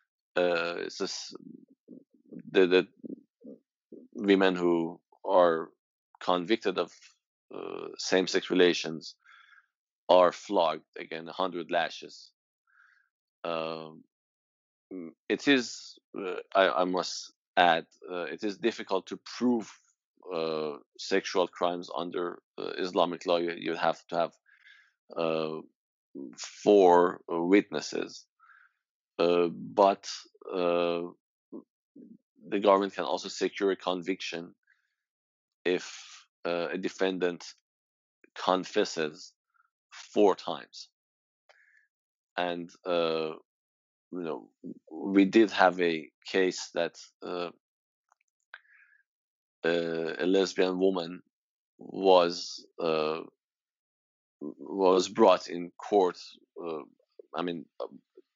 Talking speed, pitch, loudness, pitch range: 90 wpm, 90 Hz, -29 LUFS, 85-100 Hz